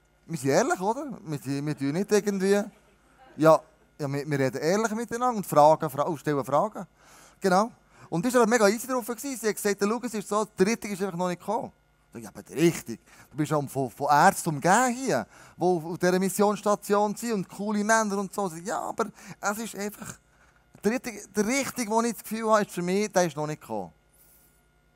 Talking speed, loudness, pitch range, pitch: 210 wpm, -26 LUFS, 160-215 Hz, 200 Hz